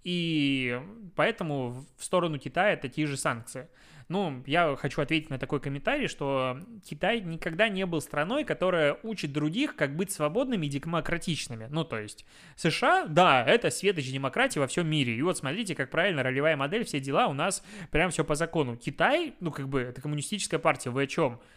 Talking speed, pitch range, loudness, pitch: 185 wpm, 140-180 Hz, -28 LUFS, 155 Hz